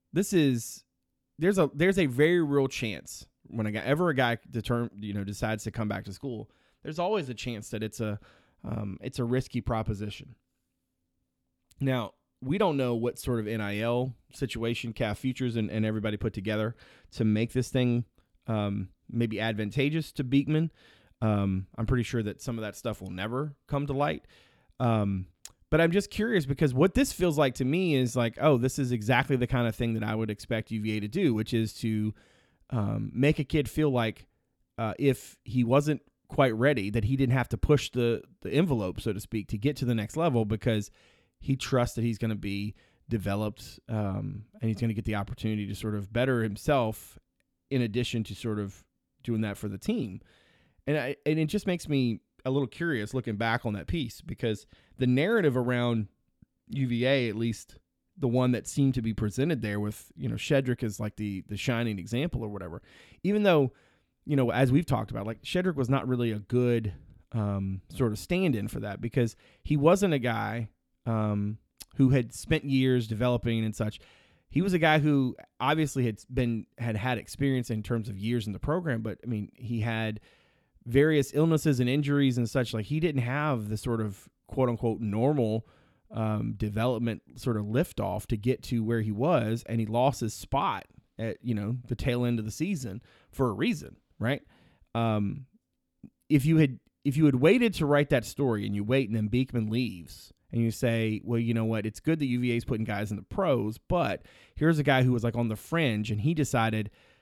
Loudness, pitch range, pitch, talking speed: -29 LUFS, 110-135 Hz, 120 Hz, 200 wpm